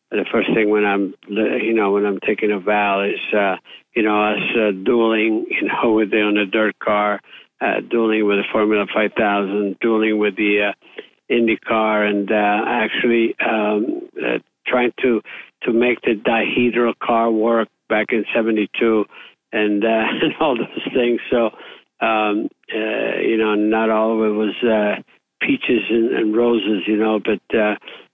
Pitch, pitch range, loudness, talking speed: 110 Hz, 105-115 Hz, -18 LUFS, 175 wpm